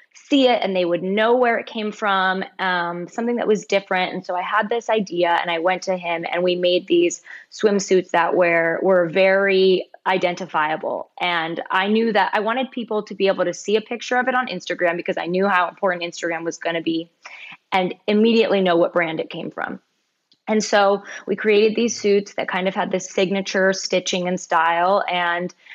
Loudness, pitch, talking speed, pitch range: -20 LUFS, 190 Hz, 205 wpm, 175-210 Hz